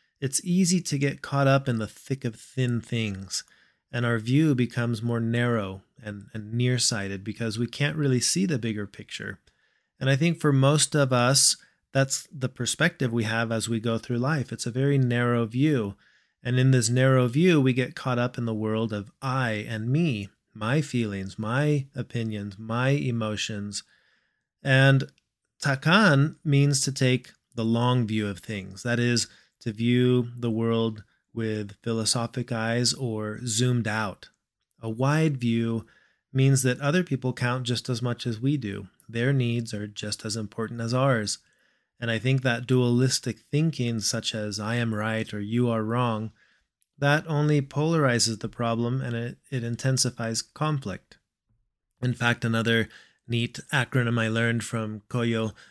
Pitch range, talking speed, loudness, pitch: 110-135 Hz, 165 wpm, -26 LUFS, 120 Hz